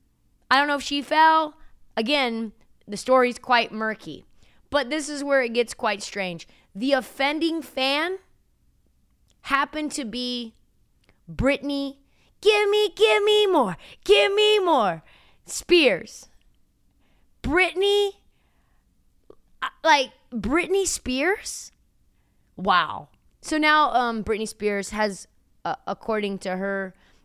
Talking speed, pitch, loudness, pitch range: 110 wpm, 275 Hz, -23 LUFS, 225-320 Hz